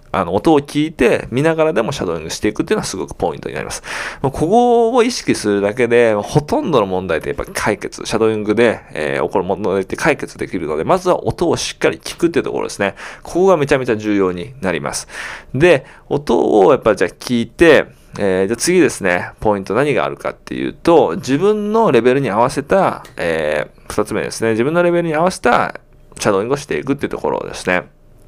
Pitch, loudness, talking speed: 145 Hz, -16 LUFS, 450 characters per minute